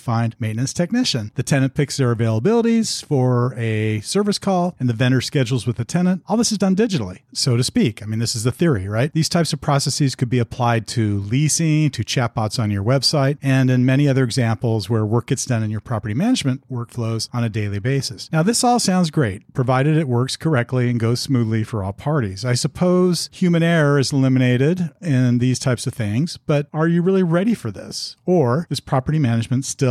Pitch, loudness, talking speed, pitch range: 130 Hz, -19 LUFS, 210 wpm, 120-155 Hz